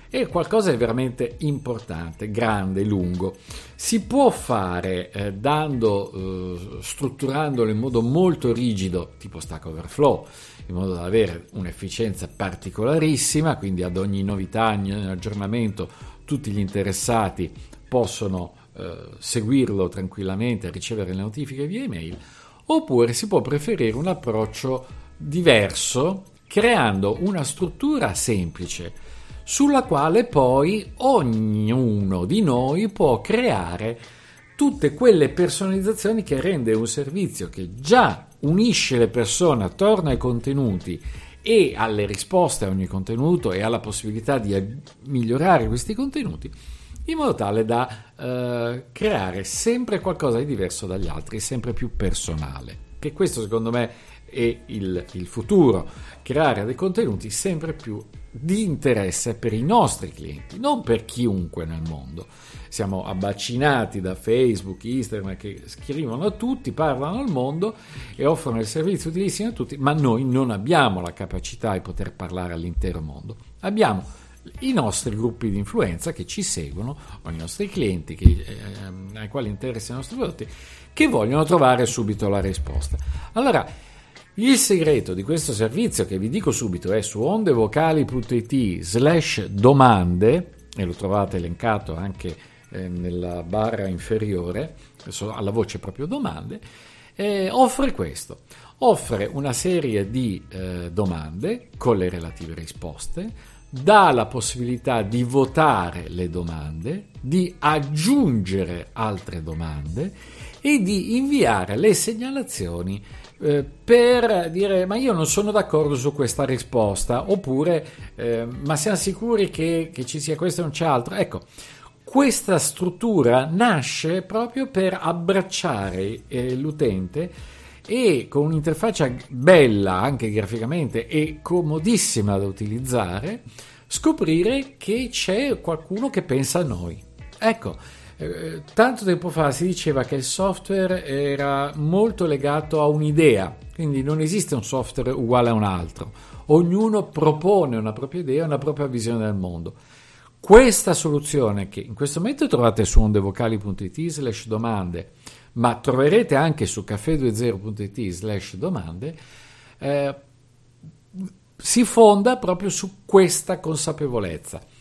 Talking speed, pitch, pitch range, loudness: 130 wpm, 125 Hz, 100-160 Hz, -22 LUFS